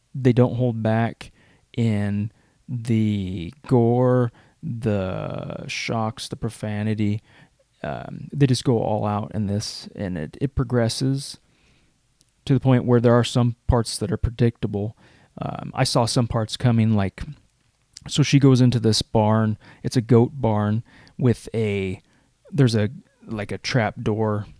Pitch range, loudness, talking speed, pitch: 105-130 Hz, -22 LUFS, 145 wpm, 115 Hz